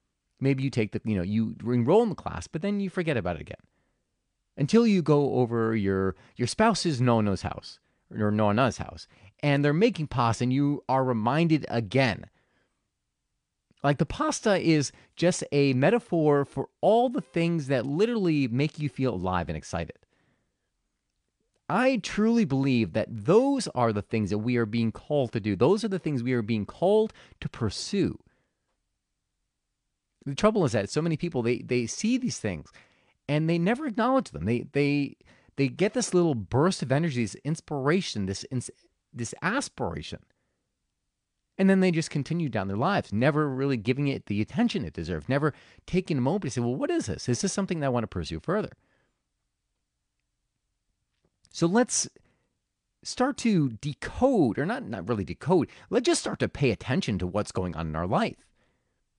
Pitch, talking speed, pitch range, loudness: 135 Hz, 175 wpm, 110-175 Hz, -27 LUFS